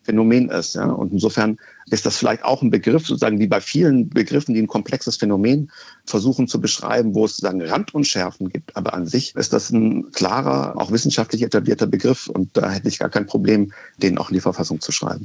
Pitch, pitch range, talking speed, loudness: 110 Hz, 95-120 Hz, 210 wpm, -19 LUFS